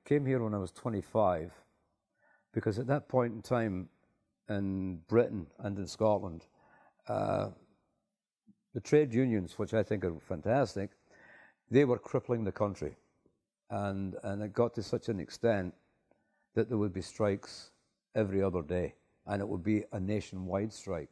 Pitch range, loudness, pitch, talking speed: 95-115 Hz, -34 LUFS, 105 Hz, 155 wpm